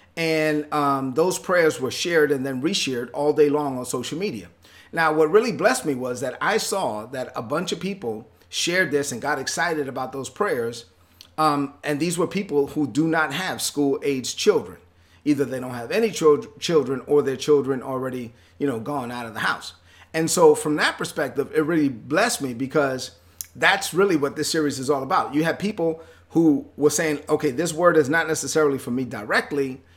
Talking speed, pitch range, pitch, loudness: 200 wpm, 130-155 Hz, 145 Hz, -22 LUFS